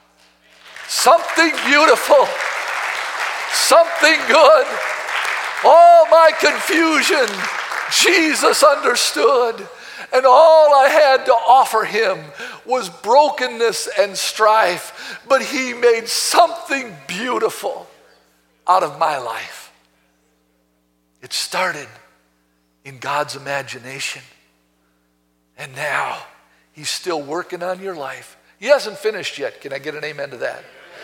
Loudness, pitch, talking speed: -15 LUFS, 225 Hz, 100 wpm